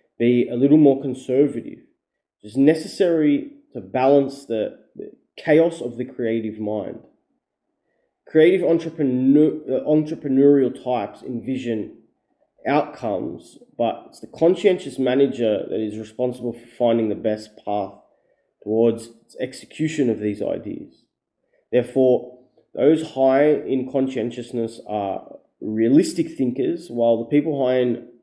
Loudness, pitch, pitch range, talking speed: -21 LUFS, 125 Hz, 115-140 Hz, 115 wpm